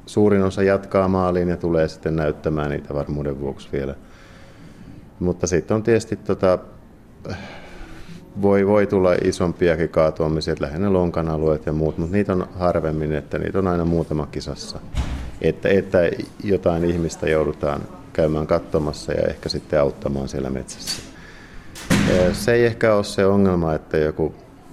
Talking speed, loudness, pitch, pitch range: 140 wpm, -21 LUFS, 85 Hz, 75-95 Hz